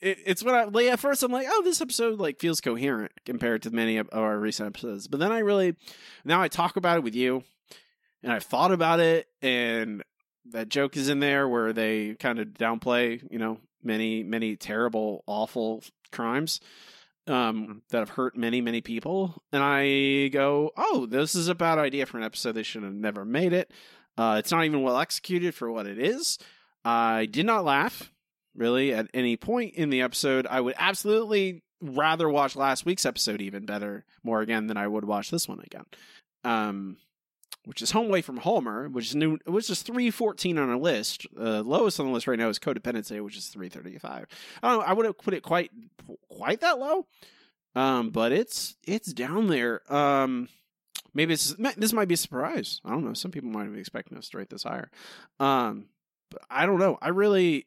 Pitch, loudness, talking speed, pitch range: 135 Hz, -27 LUFS, 200 wpm, 115-180 Hz